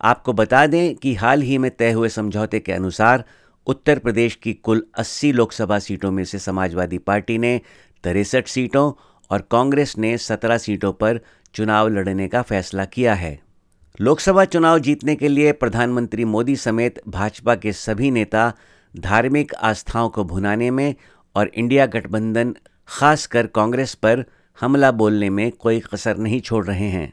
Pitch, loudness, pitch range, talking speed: 115 Hz, -19 LUFS, 105-125 Hz, 155 wpm